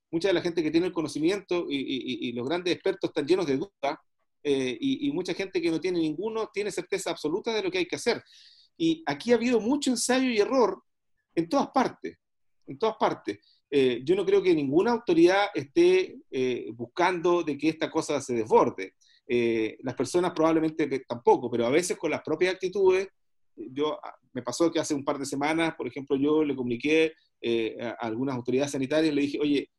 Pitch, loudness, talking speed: 185 Hz, -27 LUFS, 200 wpm